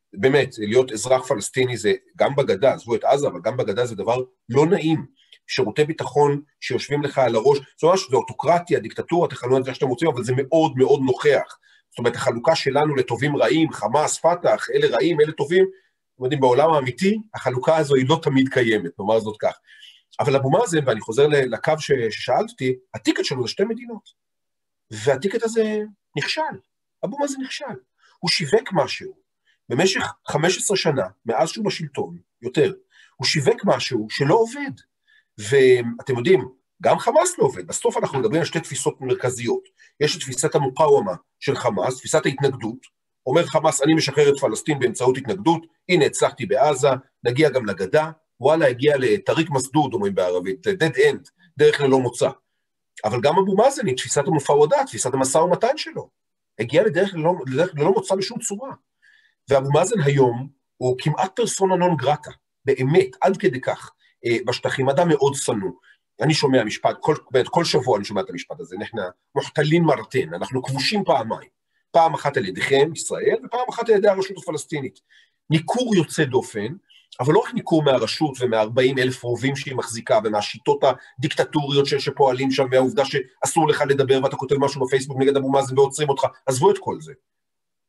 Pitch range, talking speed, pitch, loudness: 135-205 Hz, 160 wpm, 155 Hz, -21 LUFS